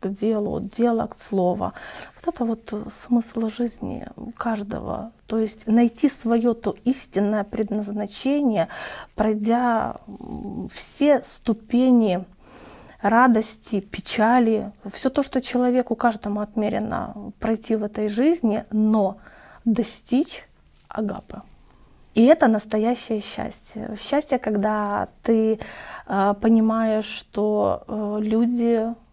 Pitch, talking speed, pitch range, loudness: 225 Hz, 95 wpm, 210-240 Hz, -23 LUFS